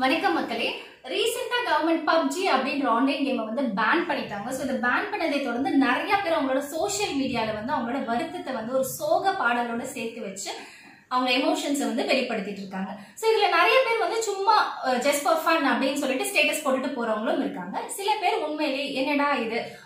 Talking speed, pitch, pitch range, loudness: 155 wpm, 280 Hz, 255-335 Hz, -25 LUFS